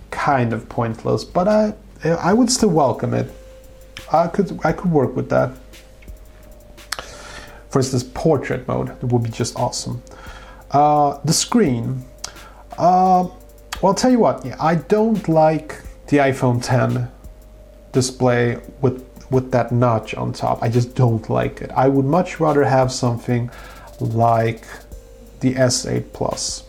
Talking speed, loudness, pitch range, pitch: 145 wpm, -19 LUFS, 115-155 Hz, 125 Hz